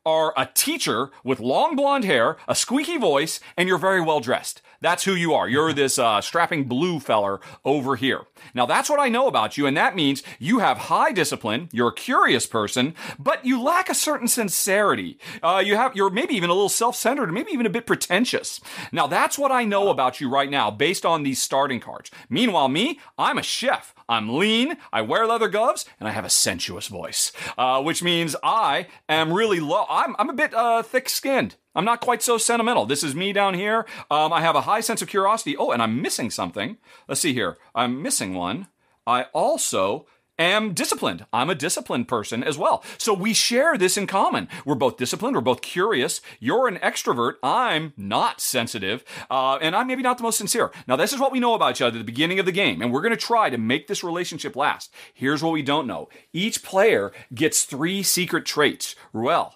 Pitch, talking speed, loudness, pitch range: 195 Hz, 210 wpm, -22 LUFS, 155-235 Hz